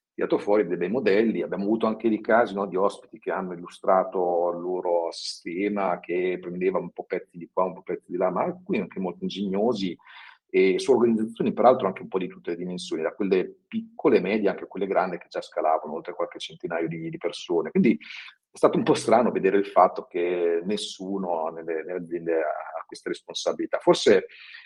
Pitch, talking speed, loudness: 100 Hz, 200 wpm, -25 LUFS